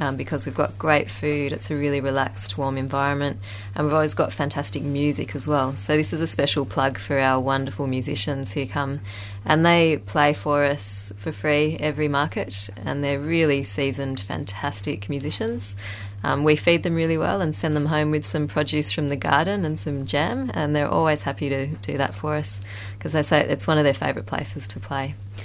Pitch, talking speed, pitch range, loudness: 140 Hz, 205 wpm, 130-150 Hz, -23 LUFS